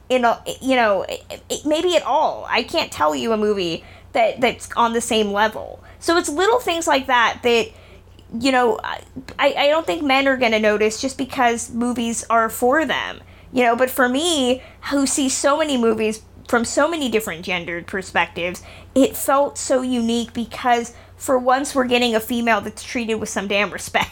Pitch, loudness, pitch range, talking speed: 245 Hz, -19 LUFS, 225-275 Hz, 185 wpm